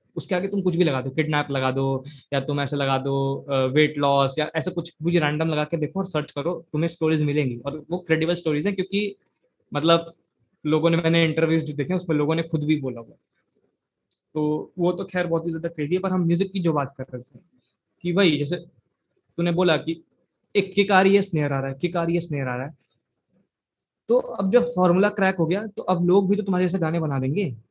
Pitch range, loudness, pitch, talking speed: 145-180 Hz, -23 LUFS, 165 Hz, 215 wpm